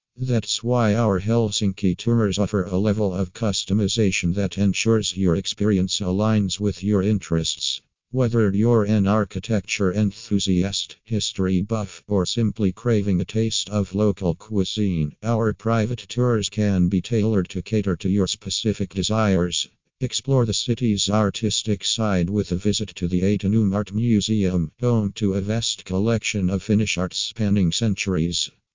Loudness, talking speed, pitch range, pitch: -22 LUFS, 140 wpm, 95-110 Hz, 100 Hz